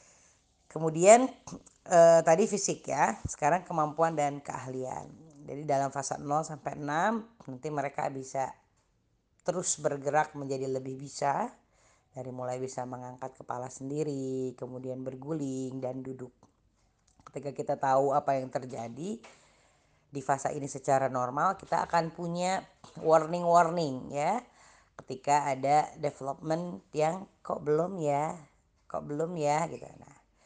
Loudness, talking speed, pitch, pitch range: -30 LUFS, 120 wpm, 145 Hz, 130-160 Hz